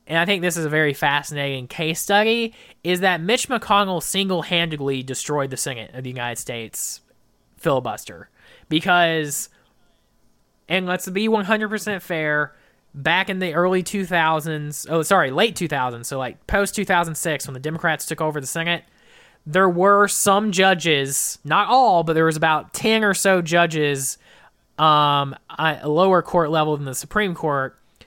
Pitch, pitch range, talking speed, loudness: 165 Hz, 145-190 Hz, 170 wpm, -20 LUFS